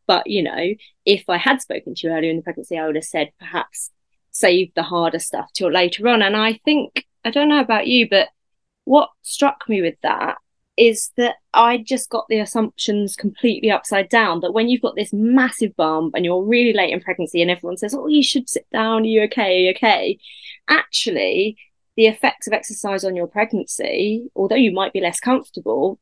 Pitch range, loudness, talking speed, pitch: 185-240 Hz, -18 LUFS, 210 wpm, 215 Hz